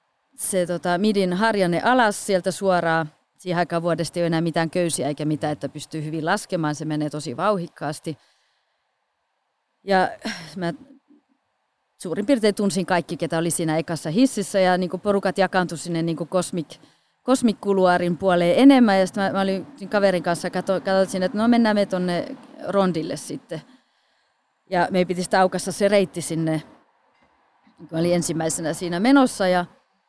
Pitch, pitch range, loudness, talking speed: 180 Hz, 165-200 Hz, -22 LUFS, 155 wpm